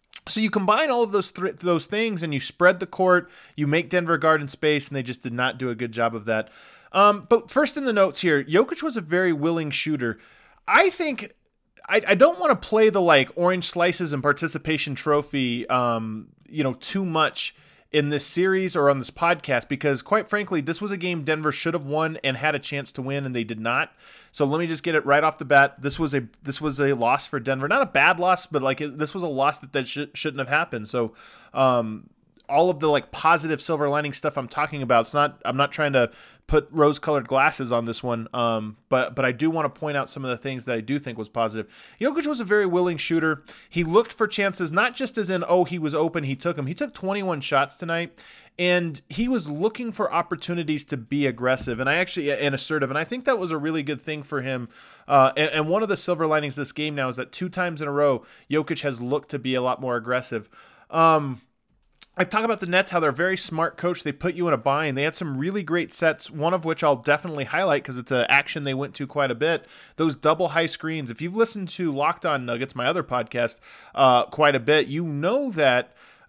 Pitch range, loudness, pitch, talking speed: 135-180 Hz, -23 LUFS, 155 Hz, 245 wpm